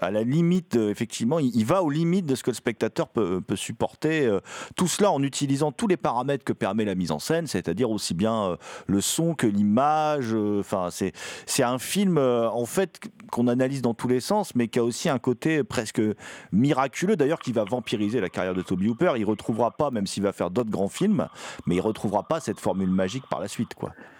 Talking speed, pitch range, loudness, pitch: 230 wpm, 110-150 Hz, -25 LUFS, 120 Hz